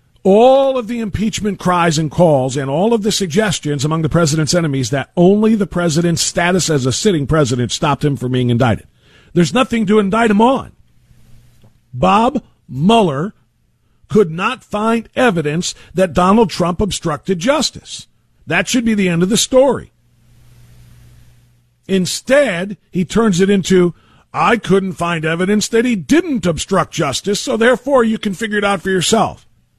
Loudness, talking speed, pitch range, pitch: -15 LUFS, 155 wpm, 150-220 Hz, 185 Hz